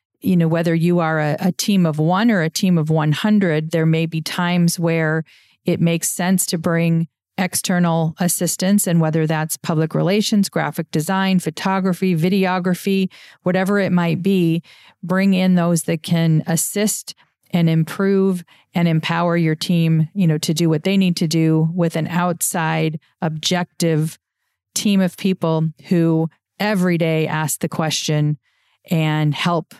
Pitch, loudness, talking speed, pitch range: 170 Hz, -18 LUFS, 155 wpm, 160-185 Hz